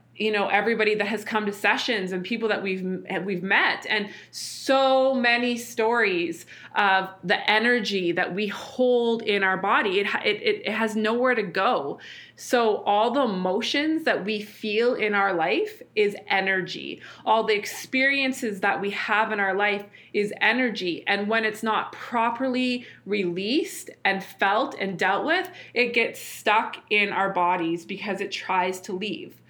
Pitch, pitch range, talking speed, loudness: 215 Hz, 195-245 Hz, 160 wpm, -24 LUFS